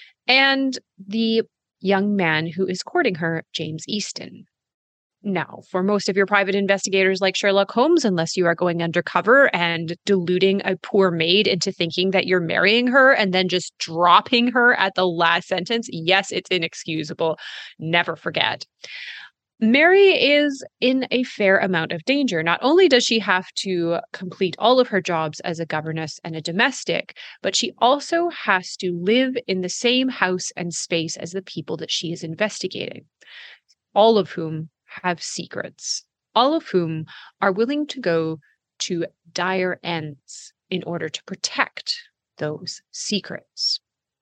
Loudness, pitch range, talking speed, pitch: -20 LUFS, 170-225 Hz, 155 wpm, 185 Hz